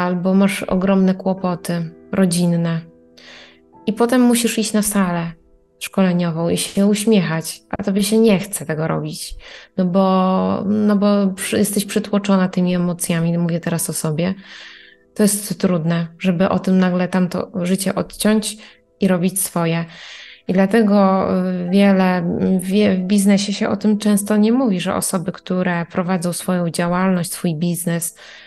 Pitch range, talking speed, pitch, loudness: 175-205 Hz, 140 wpm, 190 Hz, -18 LUFS